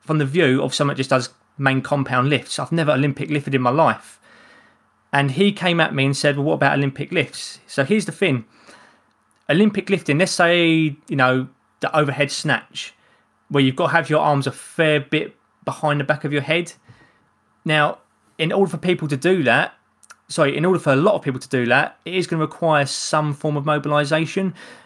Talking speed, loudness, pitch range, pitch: 210 wpm, -19 LUFS, 140-170 Hz, 150 Hz